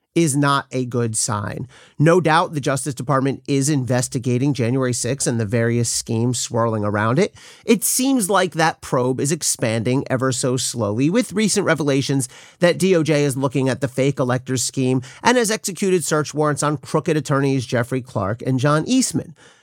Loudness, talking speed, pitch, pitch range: -19 LUFS, 170 wpm, 135 Hz, 125-160 Hz